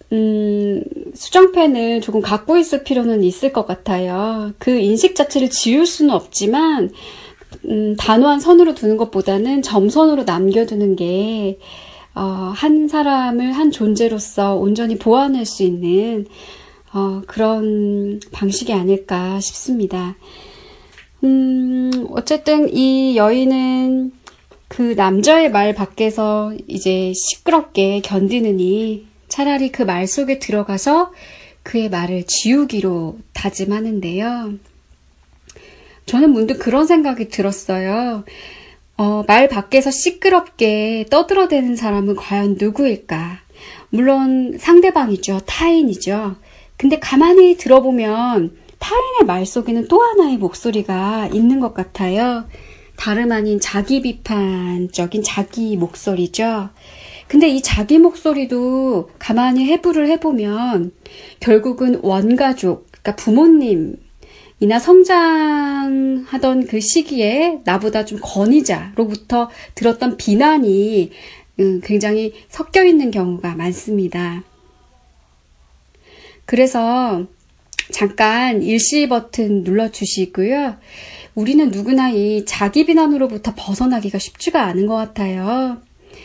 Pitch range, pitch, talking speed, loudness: 200-275 Hz, 225 Hz, 240 characters per minute, -16 LUFS